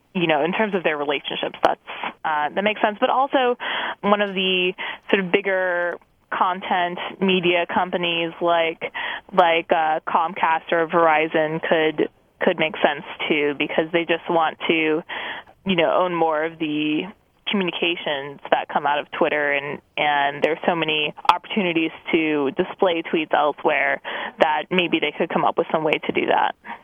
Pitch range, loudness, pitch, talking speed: 155-190 Hz, -21 LUFS, 170 Hz, 165 wpm